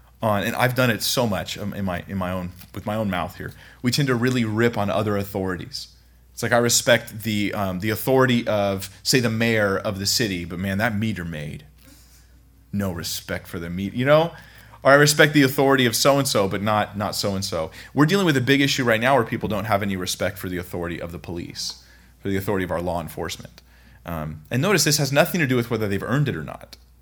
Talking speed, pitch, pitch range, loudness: 240 wpm, 105 Hz, 90-125 Hz, -22 LUFS